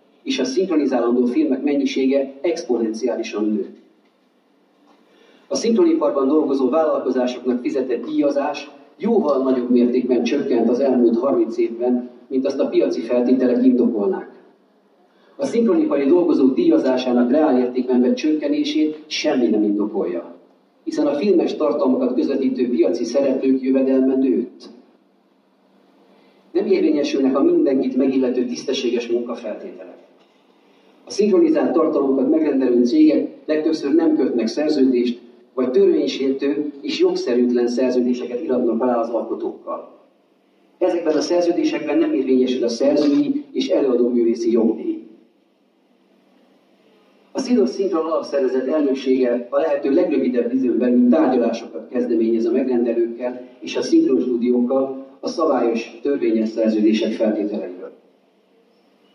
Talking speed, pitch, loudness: 105 wpm, 135 Hz, -19 LUFS